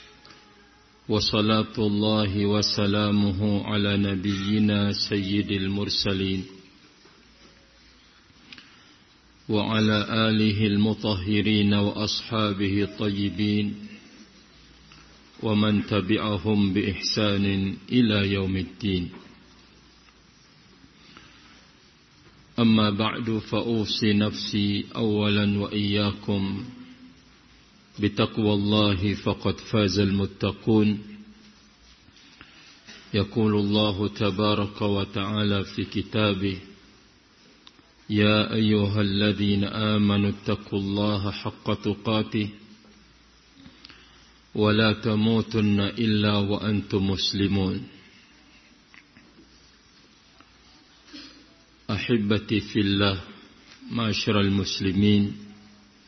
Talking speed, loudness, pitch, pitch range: 55 wpm, -24 LUFS, 105 Hz, 100-105 Hz